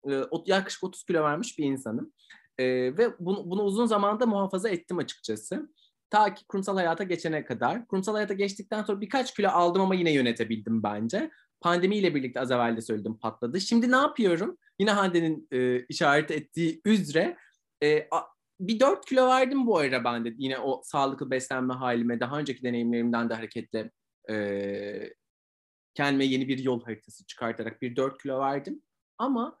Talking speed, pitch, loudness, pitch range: 160 wpm, 150 Hz, -28 LUFS, 120-205 Hz